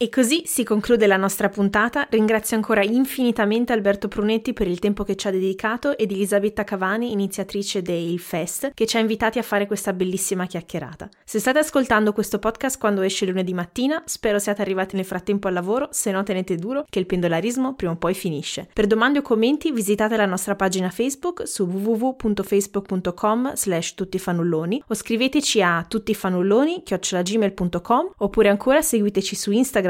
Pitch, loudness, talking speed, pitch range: 210 Hz, -22 LUFS, 165 wpm, 190-230 Hz